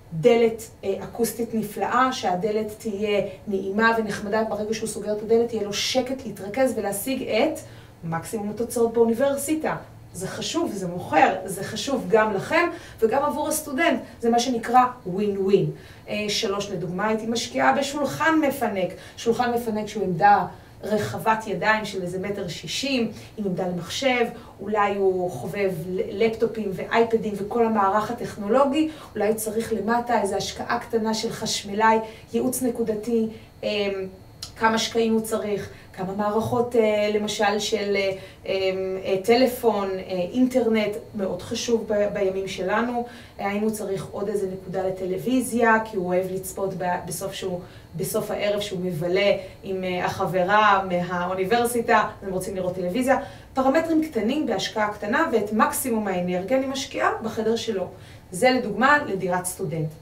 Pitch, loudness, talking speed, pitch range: 215 Hz, -24 LUFS, 125 wpm, 195-230 Hz